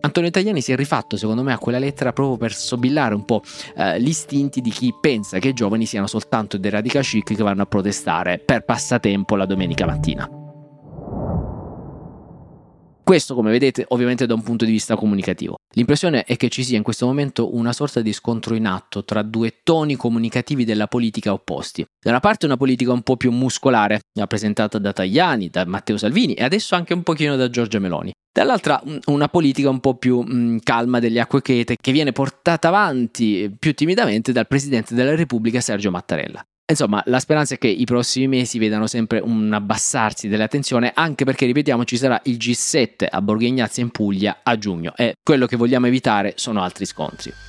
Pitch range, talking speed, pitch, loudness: 110-135 Hz, 185 wpm, 120 Hz, -19 LUFS